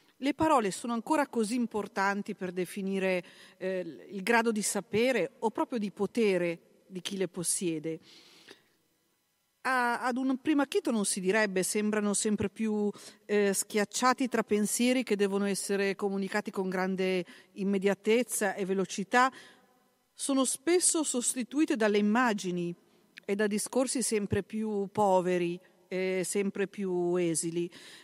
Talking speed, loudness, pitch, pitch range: 130 wpm, -30 LUFS, 205 Hz, 190-240 Hz